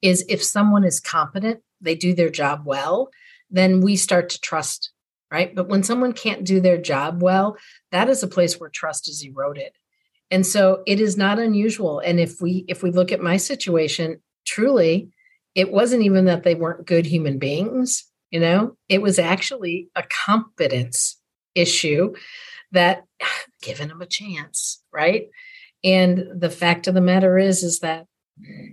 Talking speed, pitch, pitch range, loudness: 165 wpm, 185 Hz, 170-205 Hz, -20 LUFS